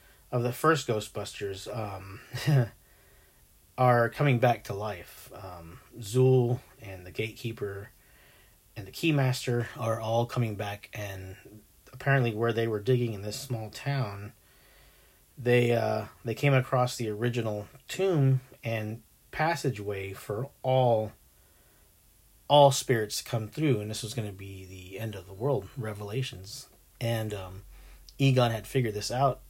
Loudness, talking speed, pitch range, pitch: -29 LUFS, 140 wpm, 100-130 Hz, 115 Hz